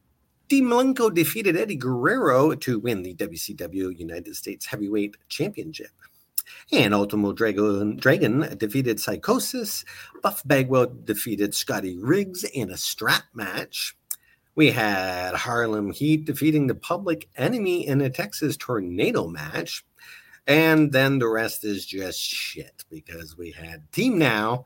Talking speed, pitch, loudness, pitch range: 125 wpm, 120 Hz, -24 LUFS, 105-155 Hz